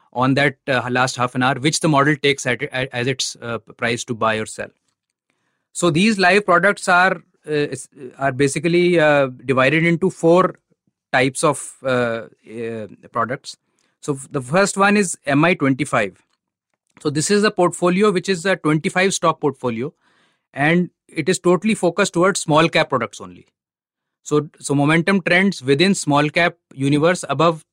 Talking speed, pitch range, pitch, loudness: 170 wpm, 135-180 Hz, 155 Hz, -18 LUFS